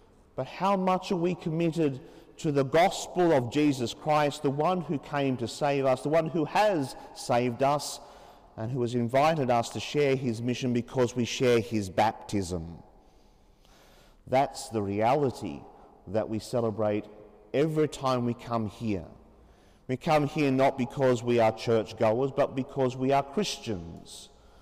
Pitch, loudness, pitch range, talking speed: 130 Hz, -28 LUFS, 110-145 Hz, 155 wpm